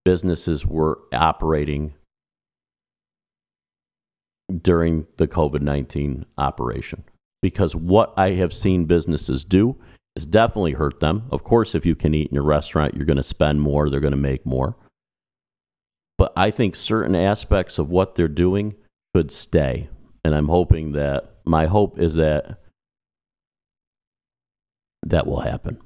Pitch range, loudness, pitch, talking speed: 75-95 Hz, -21 LUFS, 80 Hz, 135 wpm